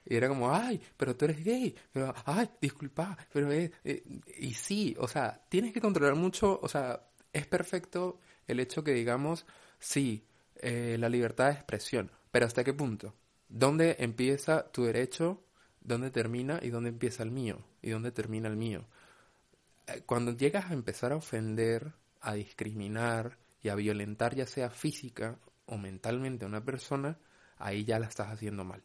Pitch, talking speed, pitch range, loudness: 125 Hz, 170 wpm, 115-155 Hz, -34 LUFS